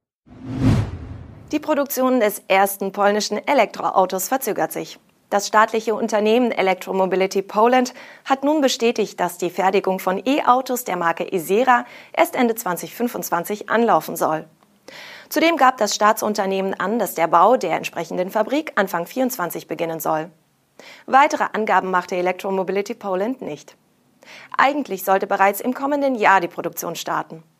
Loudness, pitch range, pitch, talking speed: -20 LUFS, 185-245 Hz, 200 Hz, 130 wpm